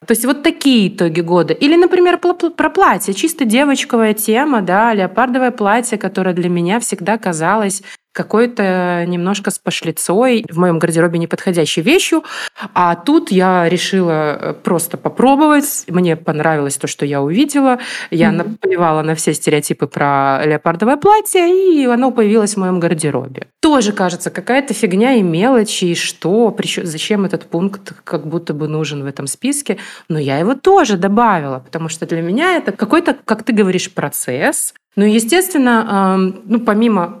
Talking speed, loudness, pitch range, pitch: 150 wpm, -14 LUFS, 170-250 Hz, 200 Hz